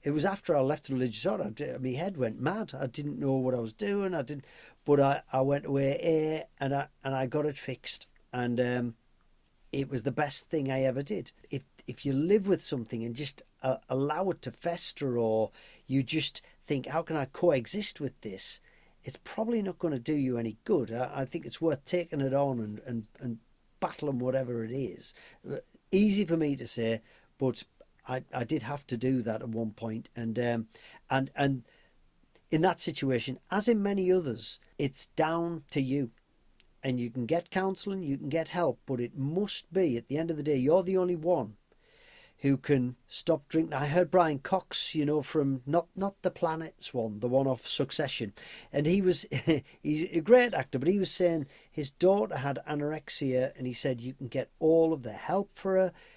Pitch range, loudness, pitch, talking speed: 130-170 Hz, -29 LUFS, 140 Hz, 205 wpm